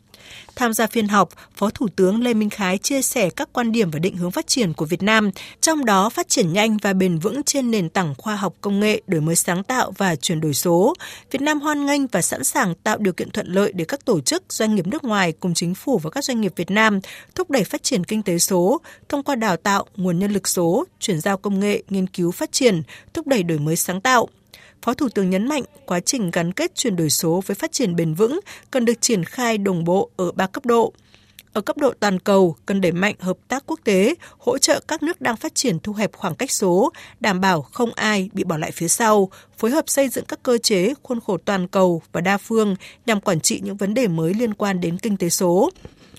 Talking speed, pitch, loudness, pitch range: 250 wpm, 205 Hz, -20 LUFS, 185-245 Hz